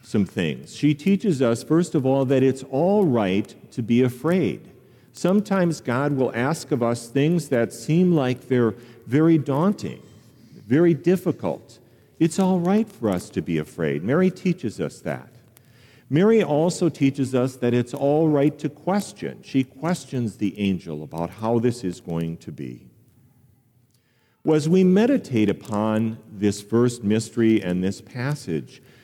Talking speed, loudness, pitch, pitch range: 155 wpm, -22 LUFS, 125 Hz, 115-160 Hz